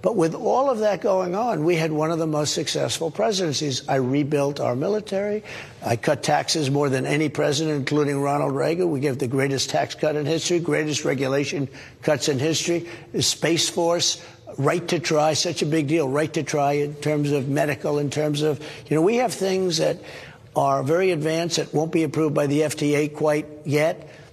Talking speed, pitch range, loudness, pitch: 195 wpm, 145-165 Hz, -22 LUFS, 155 Hz